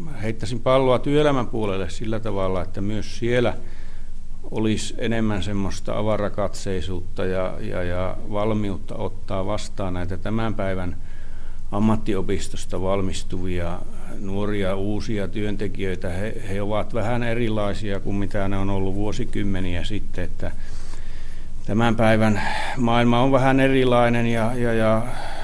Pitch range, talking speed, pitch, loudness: 95-110 Hz, 115 wpm, 100 Hz, -24 LUFS